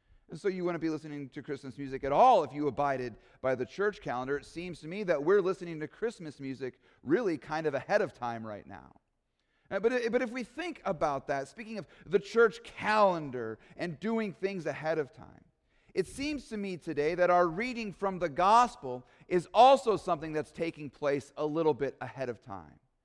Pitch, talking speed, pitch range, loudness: 160 Hz, 195 wpm, 140-200 Hz, -31 LUFS